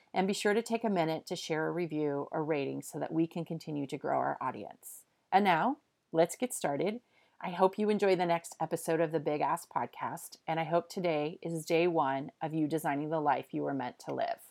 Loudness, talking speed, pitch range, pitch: -33 LUFS, 230 wpm, 155-190 Hz, 165 Hz